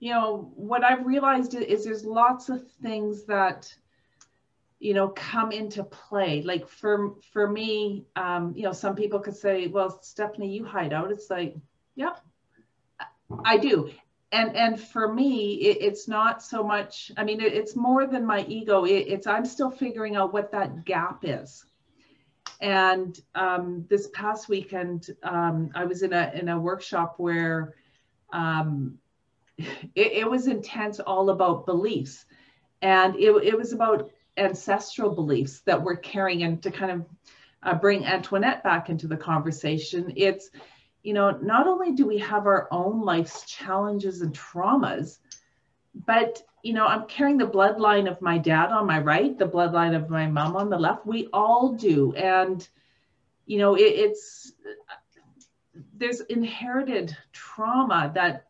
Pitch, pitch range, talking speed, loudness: 200 Hz, 175-220 Hz, 160 wpm, -25 LUFS